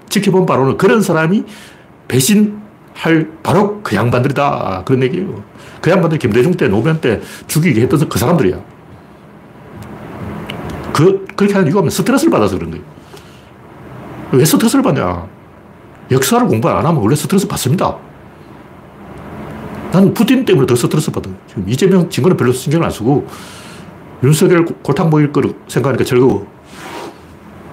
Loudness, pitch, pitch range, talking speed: -13 LUFS, 170 Hz, 140-195 Hz, 325 characters per minute